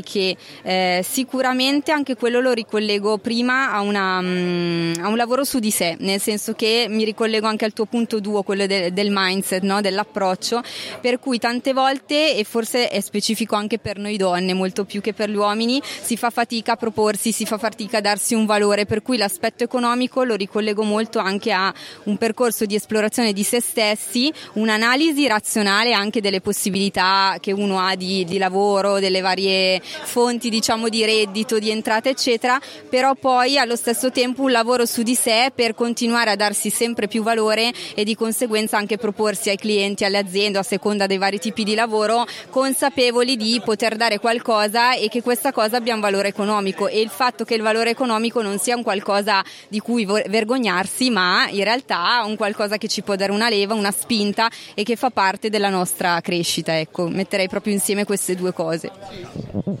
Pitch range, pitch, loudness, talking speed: 200-235 Hz, 220 Hz, -19 LUFS, 185 wpm